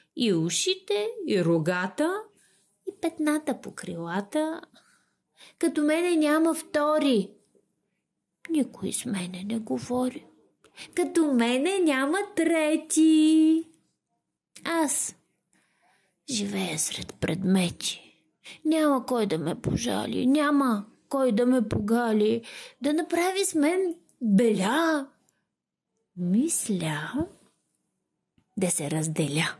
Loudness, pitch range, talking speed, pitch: -26 LUFS, 205-320 Hz, 90 wpm, 275 Hz